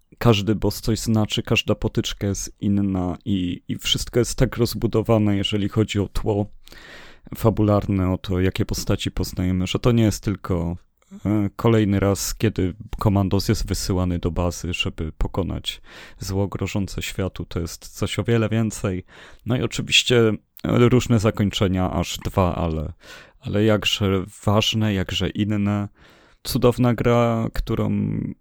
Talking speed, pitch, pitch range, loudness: 135 wpm, 100 Hz, 90-110 Hz, -22 LUFS